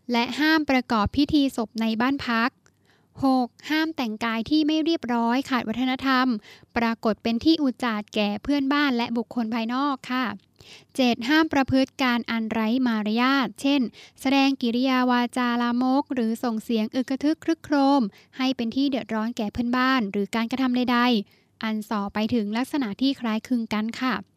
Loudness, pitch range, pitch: -24 LUFS, 230-270 Hz, 245 Hz